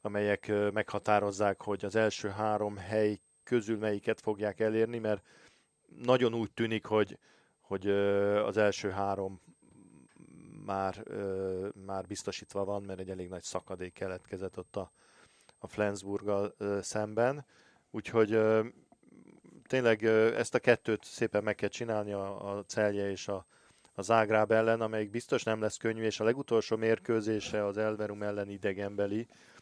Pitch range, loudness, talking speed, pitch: 100-110 Hz, -32 LUFS, 130 wpm, 105 Hz